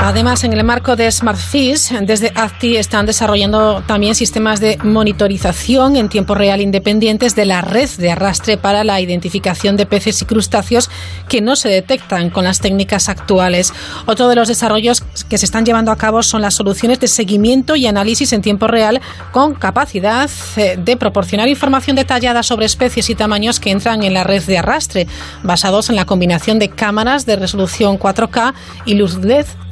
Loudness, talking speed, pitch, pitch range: -13 LUFS, 175 wpm, 215 Hz, 195-235 Hz